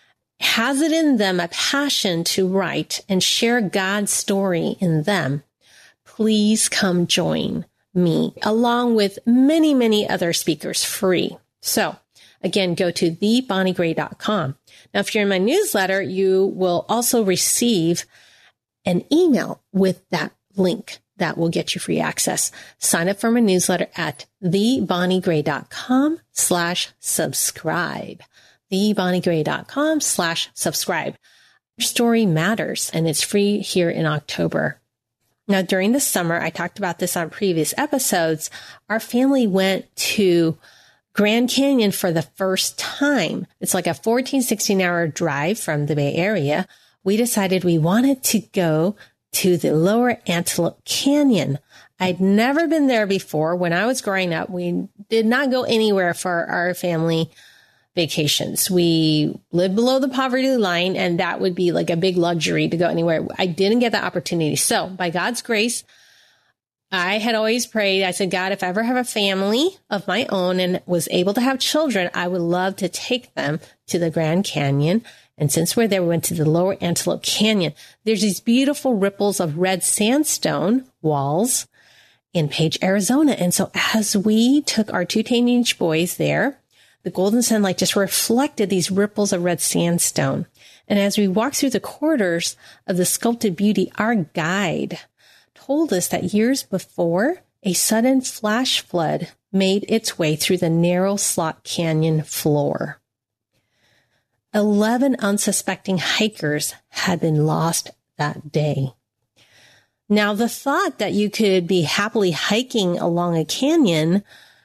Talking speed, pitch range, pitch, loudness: 150 wpm, 170-220 Hz, 190 Hz, -20 LUFS